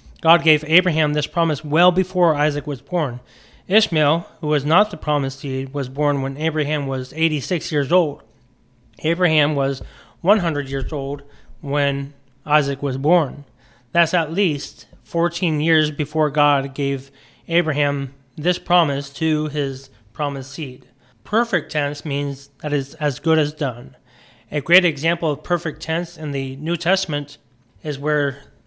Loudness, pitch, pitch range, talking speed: -20 LUFS, 150 Hz, 140-165 Hz, 145 wpm